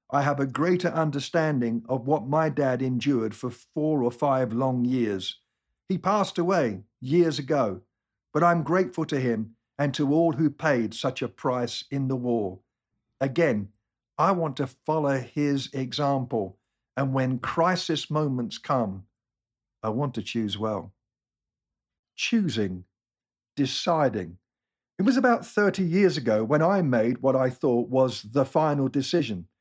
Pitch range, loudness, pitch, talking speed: 115-155 Hz, -26 LUFS, 135 Hz, 145 wpm